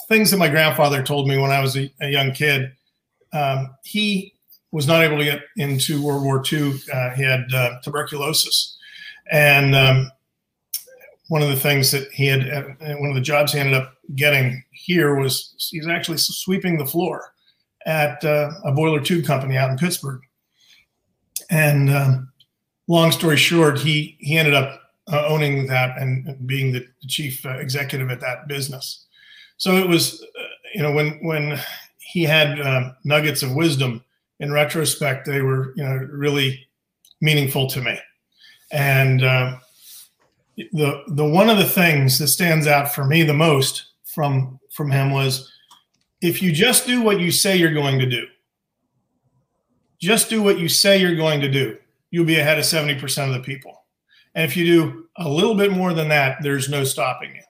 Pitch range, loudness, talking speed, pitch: 135-165 Hz, -19 LUFS, 175 wpm, 145 Hz